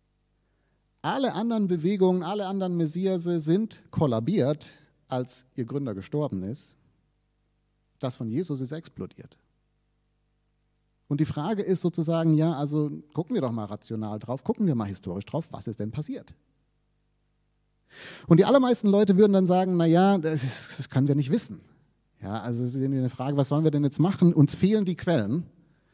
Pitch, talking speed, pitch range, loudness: 150 Hz, 160 wpm, 135-180 Hz, -26 LUFS